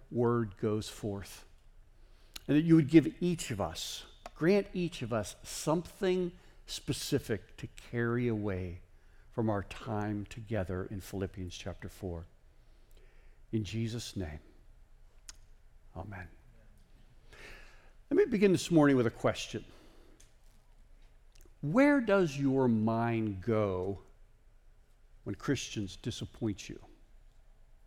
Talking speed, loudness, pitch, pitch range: 105 wpm, -32 LUFS, 110 Hz, 100-140 Hz